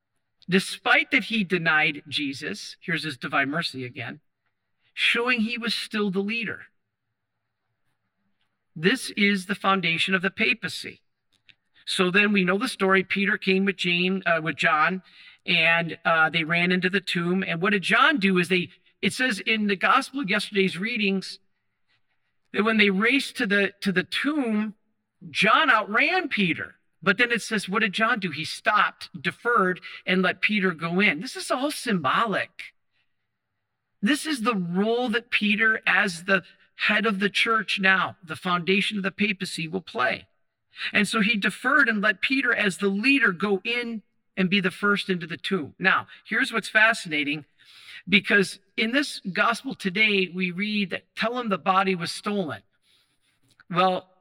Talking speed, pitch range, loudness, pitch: 165 wpm, 150-210 Hz, -23 LUFS, 190 Hz